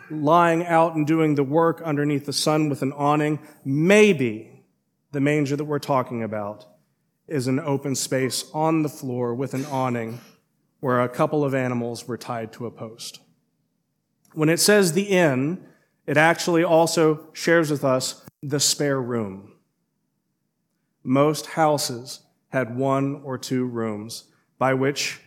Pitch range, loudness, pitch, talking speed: 130-155 Hz, -22 LUFS, 145 Hz, 145 wpm